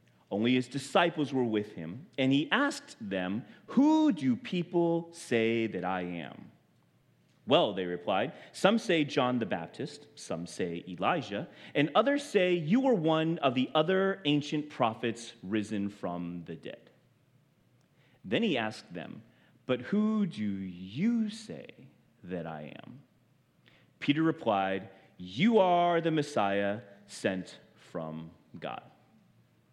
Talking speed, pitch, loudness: 130 wpm, 140 Hz, -30 LUFS